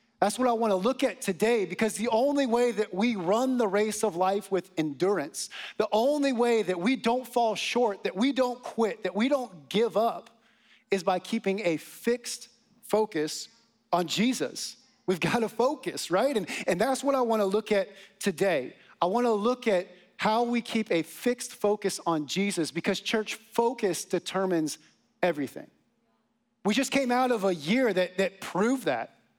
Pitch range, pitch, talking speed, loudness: 190-240 Hz, 220 Hz, 185 wpm, -28 LUFS